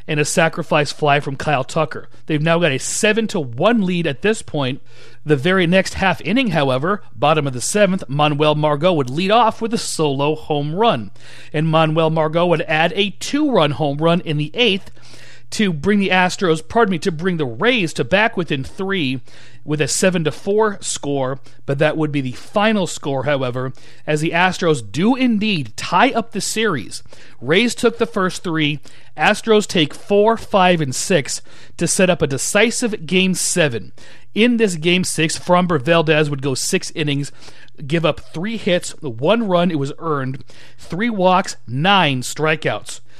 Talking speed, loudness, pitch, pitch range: 180 wpm, -17 LUFS, 165 Hz, 145-195 Hz